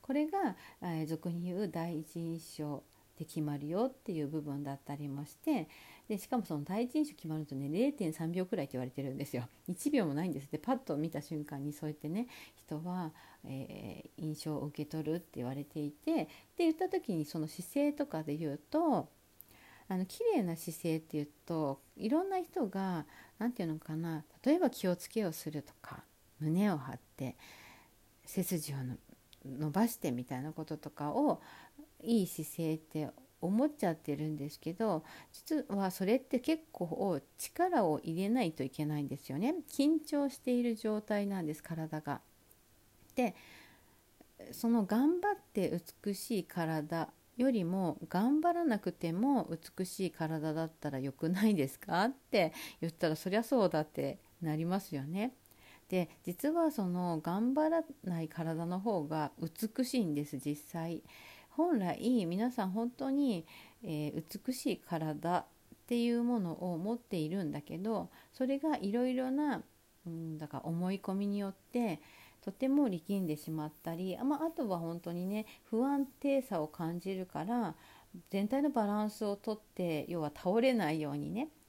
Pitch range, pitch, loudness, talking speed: 155-235 Hz, 175 Hz, -36 LUFS, 295 characters per minute